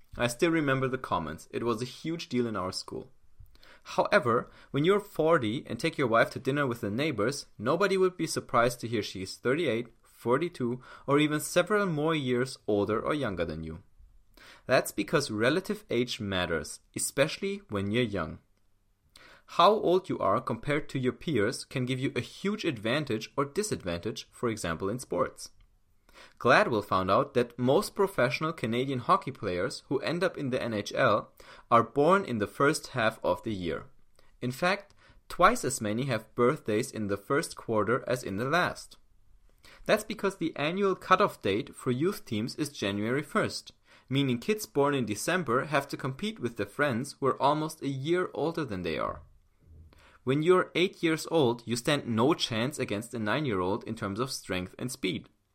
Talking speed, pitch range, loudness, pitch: 180 wpm, 110-155 Hz, -29 LUFS, 130 Hz